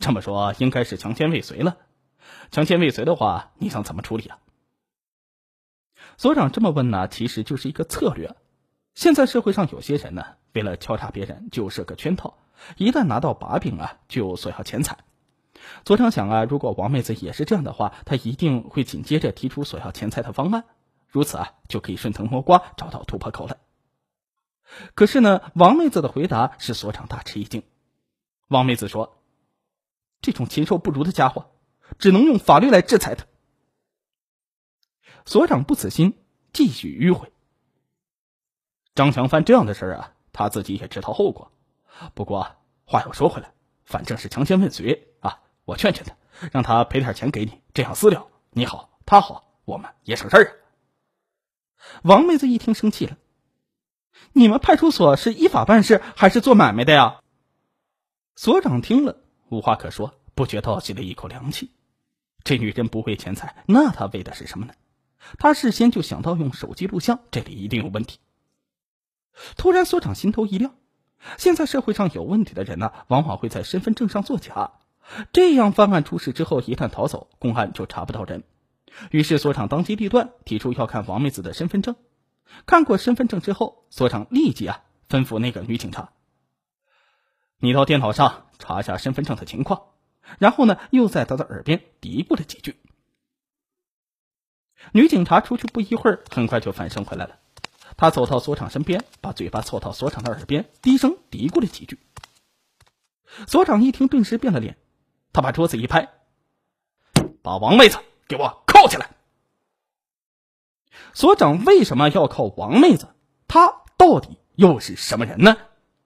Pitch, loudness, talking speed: 155 Hz, -19 LUFS, 255 characters per minute